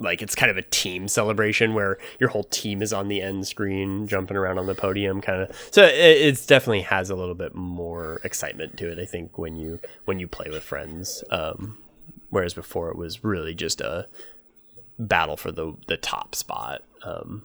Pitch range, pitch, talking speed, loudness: 90-110 Hz, 95 Hz, 205 wpm, -23 LUFS